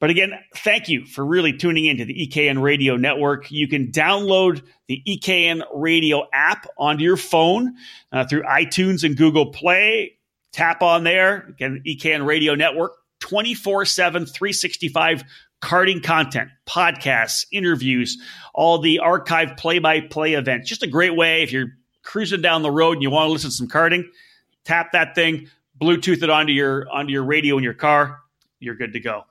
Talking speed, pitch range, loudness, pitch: 170 wpm, 145-175 Hz, -18 LUFS, 160 Hz